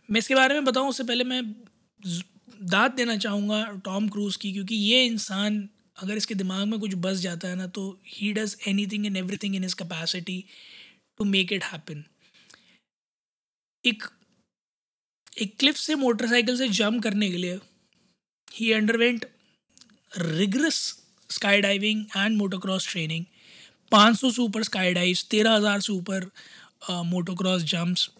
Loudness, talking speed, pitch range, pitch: -25 LUFS, 145 wpm, 185-225 Hz, 205 Hz